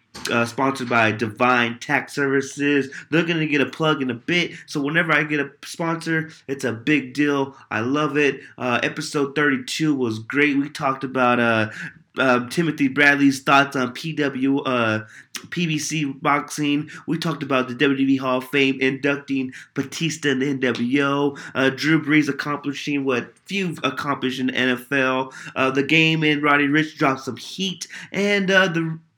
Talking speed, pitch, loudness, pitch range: 170 wpm, 140 Hz, -21 LUFS, 130-150 Hz